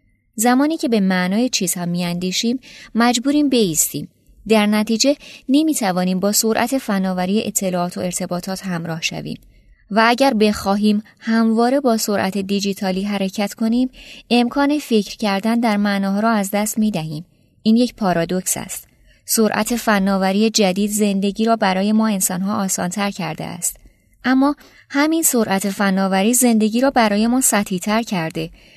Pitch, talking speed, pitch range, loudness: 210 Hz, 140 wpm, 190-235 Hz, -18 LUFS